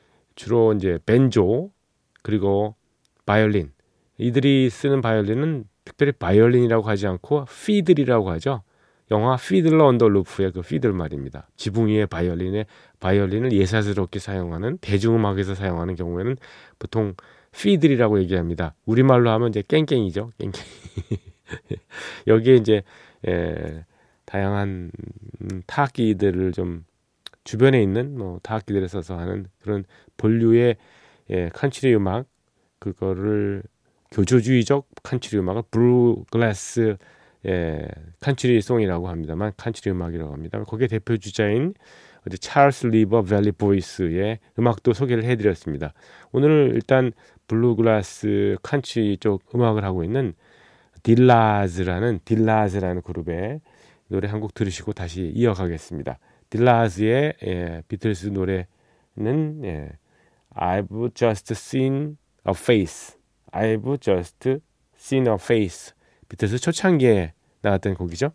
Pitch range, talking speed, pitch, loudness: 95-120 Hz, 300 characters per minute, 110 Hz, -22 LUFS